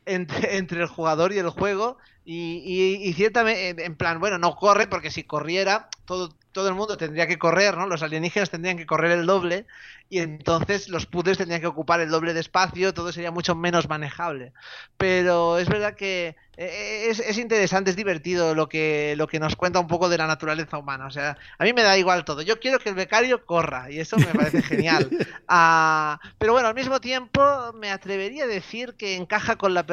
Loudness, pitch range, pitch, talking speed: -23 LUFS, 165-195 Hz, 180 Hz, 210 wpm